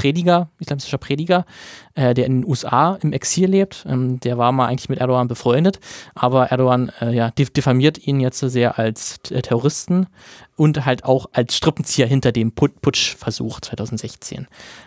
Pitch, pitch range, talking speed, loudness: 130 Hz, 125-150 Hz, 145 wpm, -19 LUFS